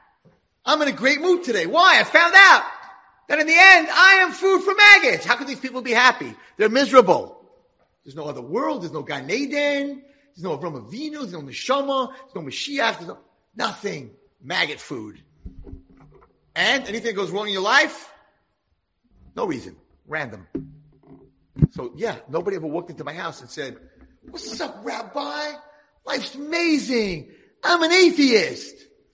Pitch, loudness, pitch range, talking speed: 275 Hz, -17 LUFS, 215-315 Hz, 165 wpm